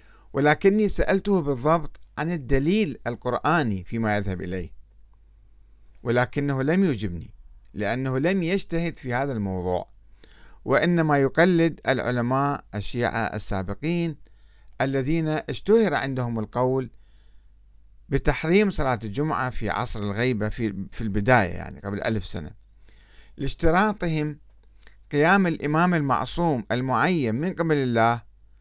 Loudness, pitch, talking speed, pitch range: -24 LUFS, 125 Hz, 100 wpm, 105-155 Hz